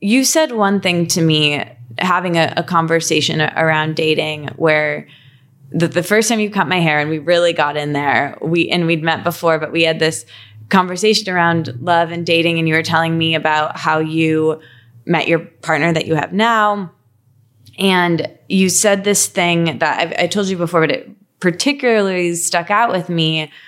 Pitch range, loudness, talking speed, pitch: 155-180 Hz, -15 LUFS, 190 wpm, 165 Hz